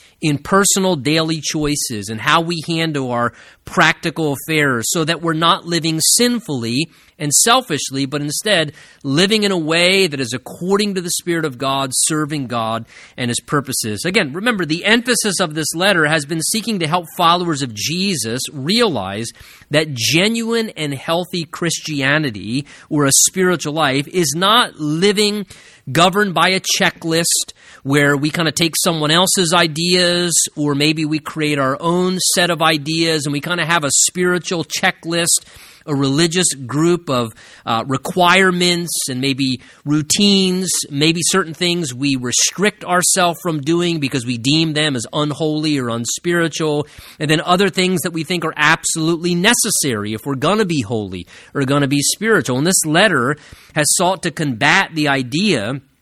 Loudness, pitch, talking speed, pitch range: -16 LUFS, 160 Hz, 160 wpm, 140-180 Hz